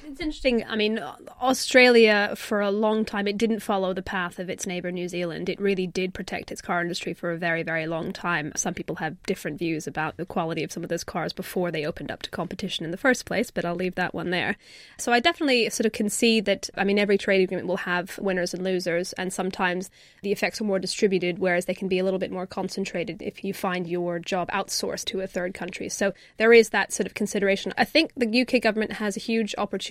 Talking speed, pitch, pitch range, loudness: 245 wpm, 190 Hz, 175-210 Hz, -25 LUFS